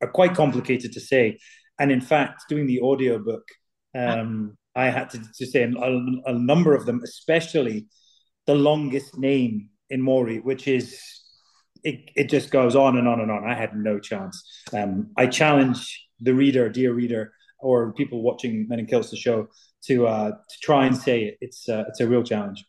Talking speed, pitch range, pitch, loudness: 185 wpm, 115-135 Hz, 125 Hz, -23 LUFS